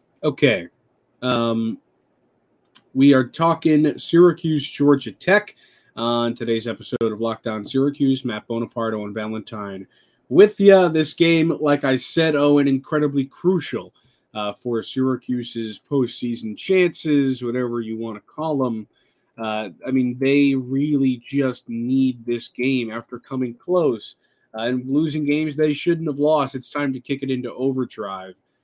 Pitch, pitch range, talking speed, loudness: 130 Hz, 115-145 Hz, 145 wpm, -20 LUFS